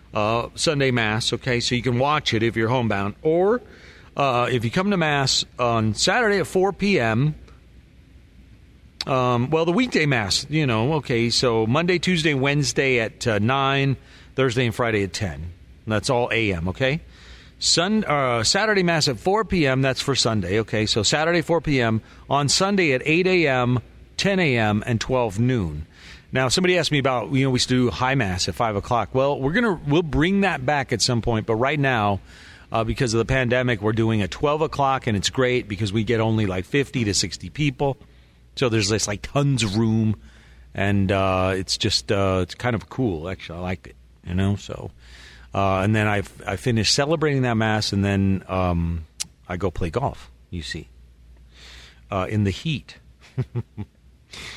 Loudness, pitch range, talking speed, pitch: -21 LUFS, 100-135 Hz, 185 wpm, 120 Hz